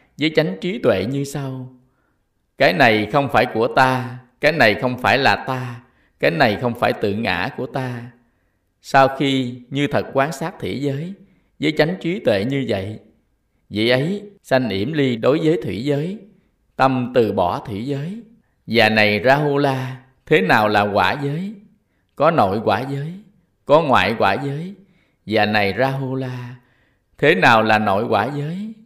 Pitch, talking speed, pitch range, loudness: 130 Hz, 175 wpm, 115-155 Hz, -18 LUFS